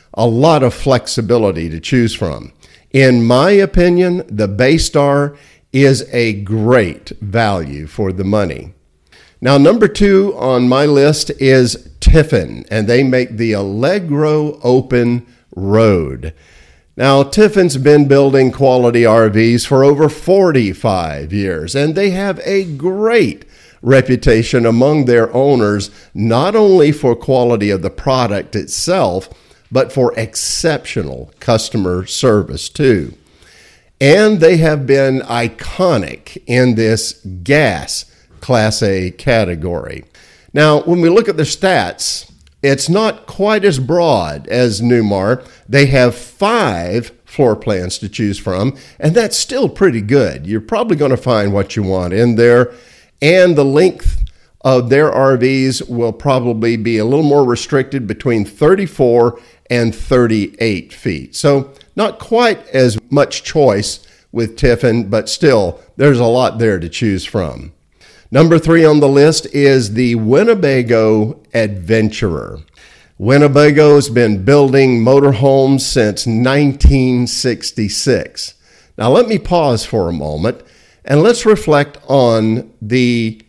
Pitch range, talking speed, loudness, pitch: 110-145 Hz, 130 wpm, -12 LUFS, 125 Hz